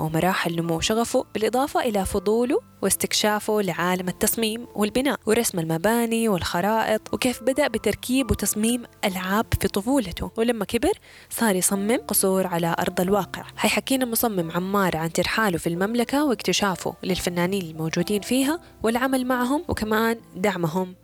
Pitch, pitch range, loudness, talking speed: 210 Hz, 185-240 Hz, -23 LUFS, 125 wpm